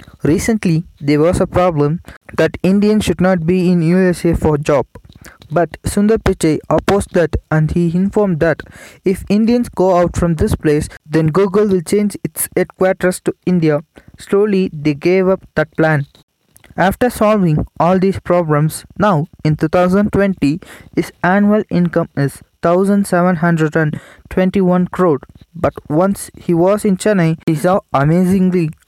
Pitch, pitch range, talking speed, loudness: 180 Hz, 155-190 Hz, 140 wpm, -15 LUFS